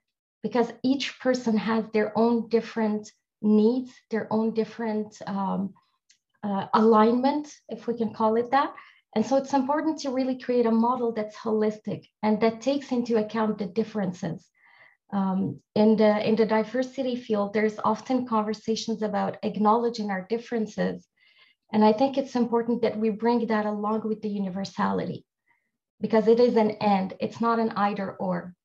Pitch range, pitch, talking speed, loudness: 210-235 Hz, 220 Hz, 155 wpm, -26 LUFS